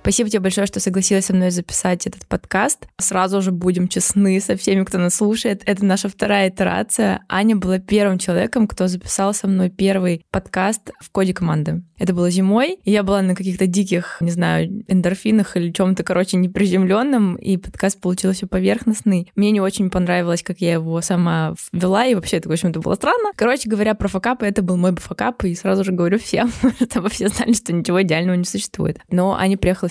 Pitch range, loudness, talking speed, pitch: 180-205 Hz, -18 LUFS, 195 wpm, 190 Hz